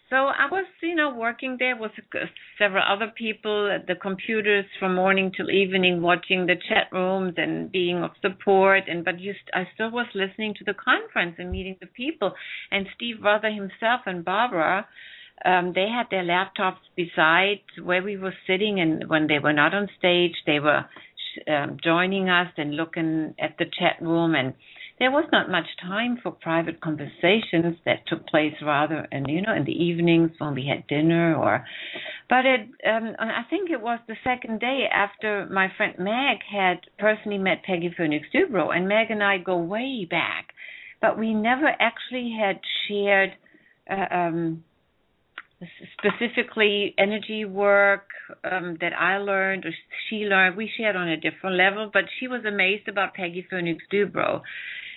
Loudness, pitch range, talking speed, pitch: -24 LUFS, 175-220 Hz, 170 wpm, 195 Hz